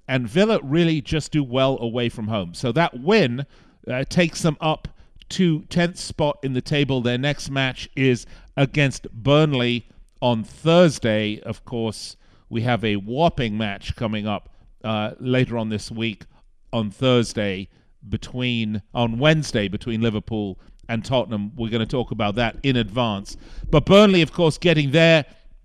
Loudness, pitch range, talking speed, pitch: -21 LUFS, 110-145 Hz, 155 wpm, 120 Hz